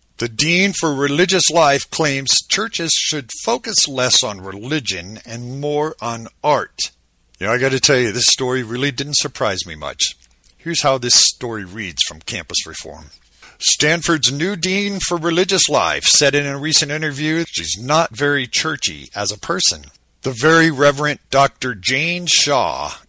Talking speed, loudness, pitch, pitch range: 165 wpm, -15 LUFS, 140 Hz, 110-160 Hz